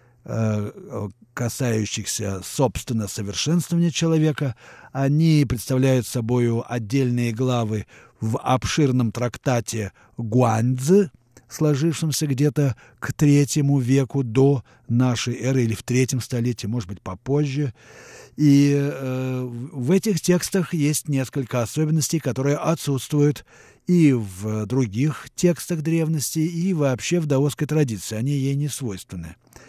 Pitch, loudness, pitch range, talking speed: 130 Hz, -22 LUFS, 120-150 Hz, 105 wpm